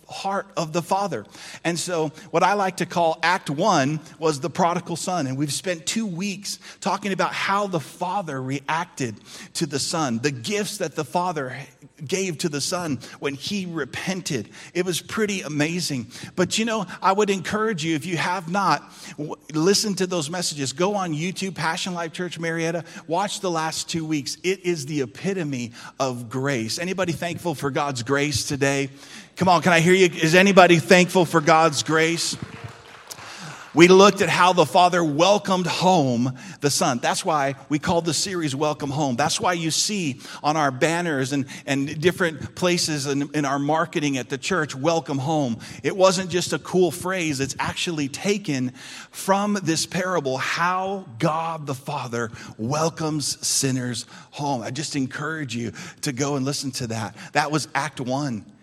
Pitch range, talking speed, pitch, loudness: 140-180 Hz, 175 wpm, 160 Hz, -22 LUFS